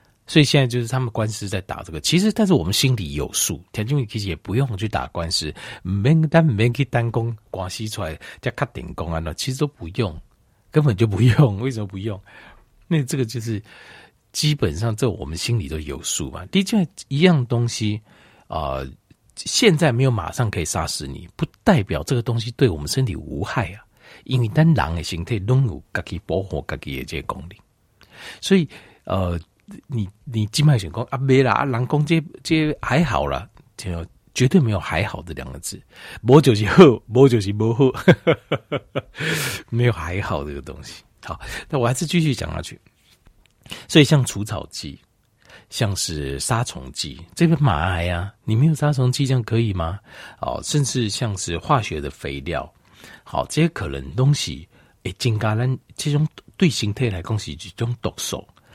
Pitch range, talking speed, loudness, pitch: 95-135 Hz, 265 characters per minute, -21 LUFS, 115 Hz